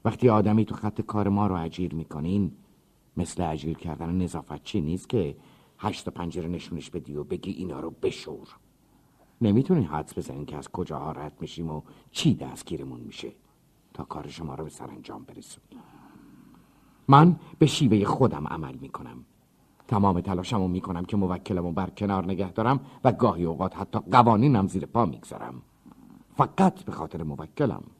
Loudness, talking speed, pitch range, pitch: -26 LUFS, 155 wpm, 80-105 Hz, 90 Hz